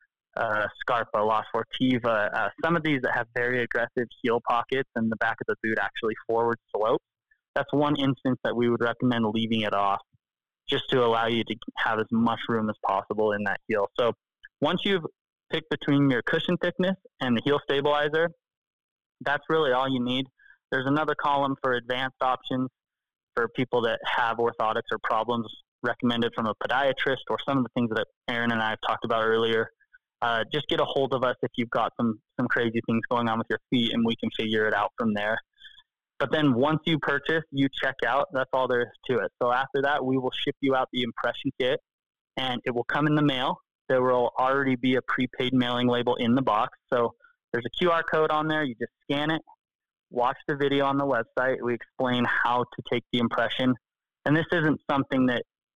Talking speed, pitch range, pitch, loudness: 210 wpm, 120-145 Hz, 130 Hz, -26 LUFS